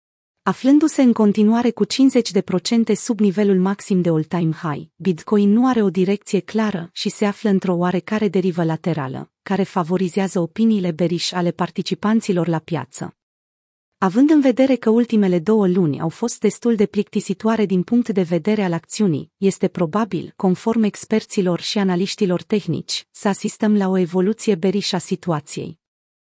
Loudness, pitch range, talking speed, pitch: -19 LUFS, 175-215 Hz, 150 wpm, 195 Hz